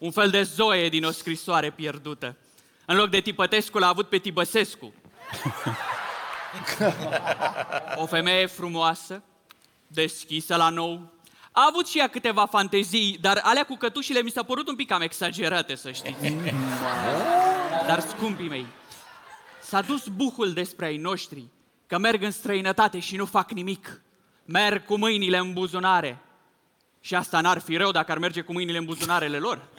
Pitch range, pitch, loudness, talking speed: 165-210 Hz, 185 Hz, -25 LUFS, 155 wpm